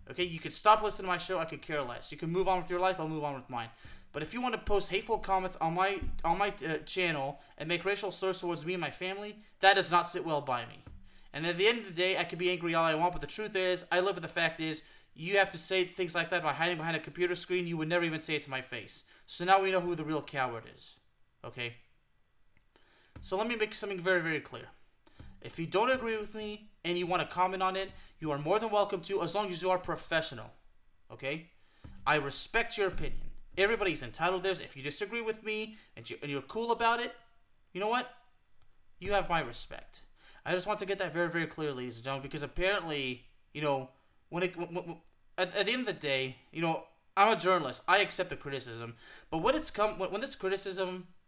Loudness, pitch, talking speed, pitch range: -32 LUFS, 175 Hz, 250 wpm, 150-195 Hz